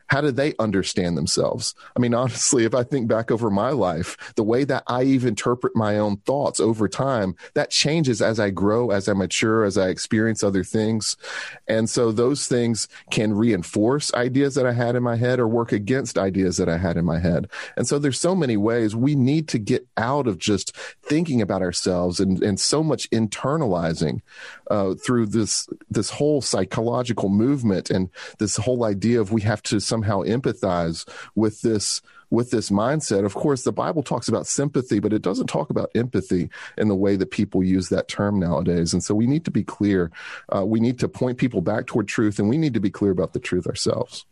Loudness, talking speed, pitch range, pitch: -22 LUFS, 205 wpm, 100-125 Hz, 110 Hz